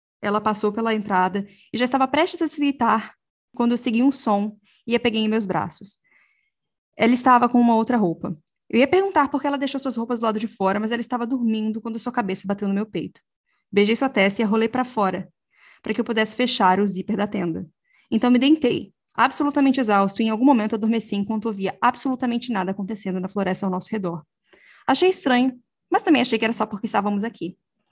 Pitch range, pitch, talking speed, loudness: 200-250 Hz, 225 Hz, 215 wpm, -22 LUFS